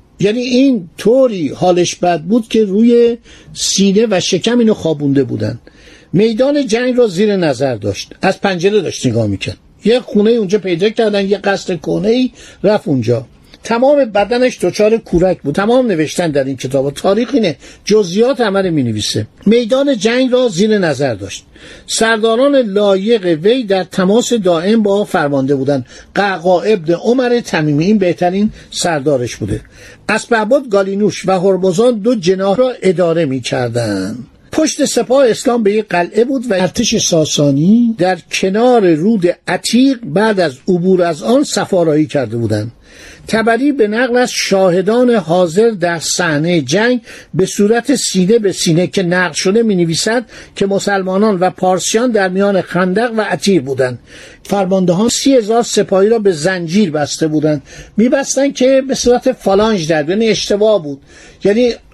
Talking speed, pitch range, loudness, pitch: 150 wpm, 175-230 Hz, -13 LUFS, 200 Hz